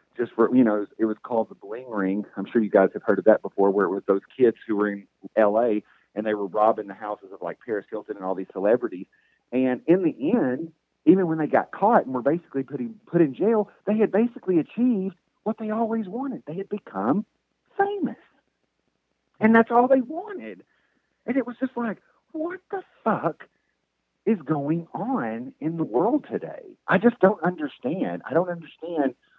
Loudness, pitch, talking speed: -24 LUFS, 180 Hz, 200 wpm